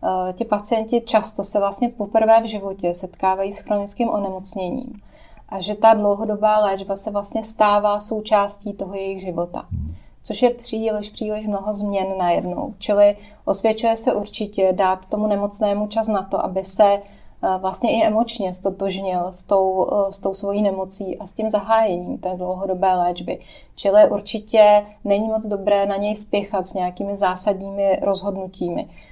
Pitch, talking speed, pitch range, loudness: 205 Hz, 150 wpm, 195-215 Hz, -20 LUFS